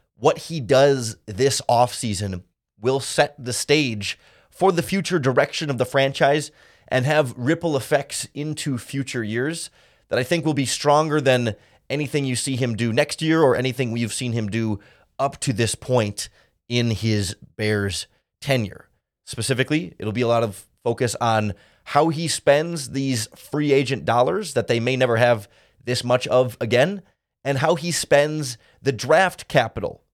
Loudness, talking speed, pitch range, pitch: -22 LUFS, 165 wpm, 115-145 Hz, 130 Hz